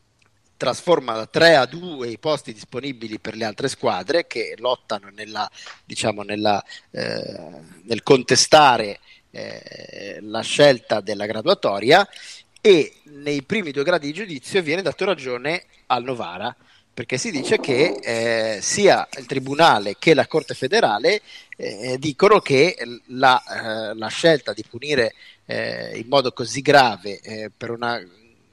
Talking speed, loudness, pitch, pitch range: 140 wpm, -20 LUFS, 130 Hz, 115-160 Hz